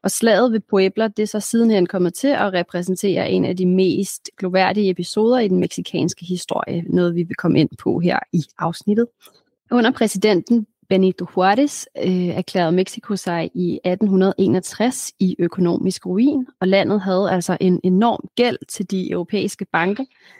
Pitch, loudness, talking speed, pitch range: 190 Hz, -19 LUFS, 160 wpm, 180-215 Hz